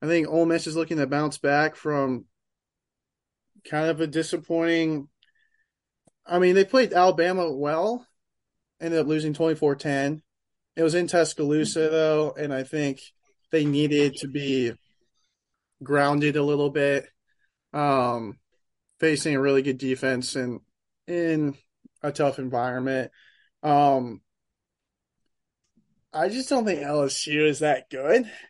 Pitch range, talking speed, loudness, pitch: 140-165 Hz, 125 wpm, -24 LUFS, 150 Hz